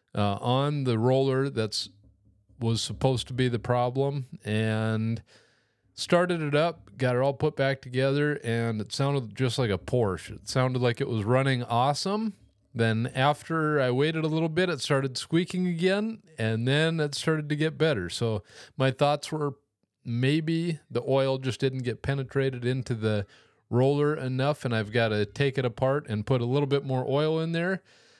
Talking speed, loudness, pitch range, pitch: 180 wpm, -27 LUFS, 115-150 Hz, 130 Hz